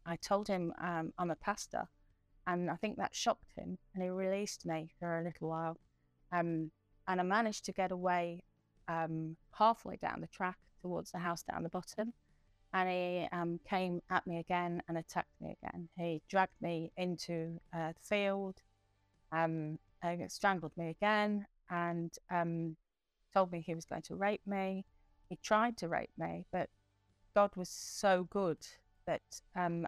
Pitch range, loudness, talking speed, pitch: 165-190 Hz, -38 LUFS, 170 wpm, 175 Hz